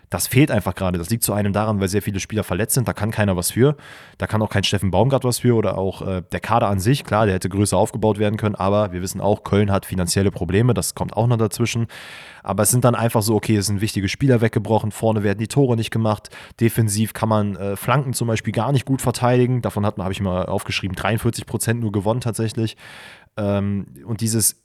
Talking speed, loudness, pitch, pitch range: 240 wpm, -20 LUFS, 110 Hz, 100-115 Hz